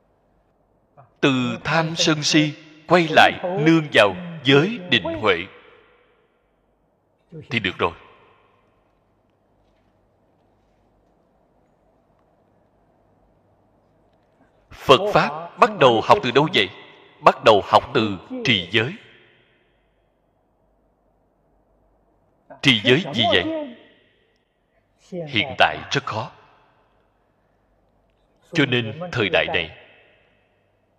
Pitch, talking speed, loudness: 160 Hz, 80 wpm, -19 LUFS